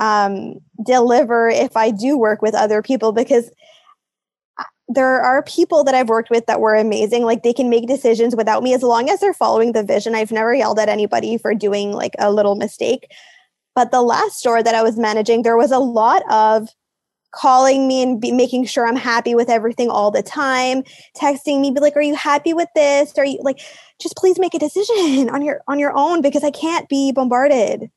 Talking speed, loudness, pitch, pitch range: 210 wpm, -16 LUFS, 250 Hz, 225-285 Hz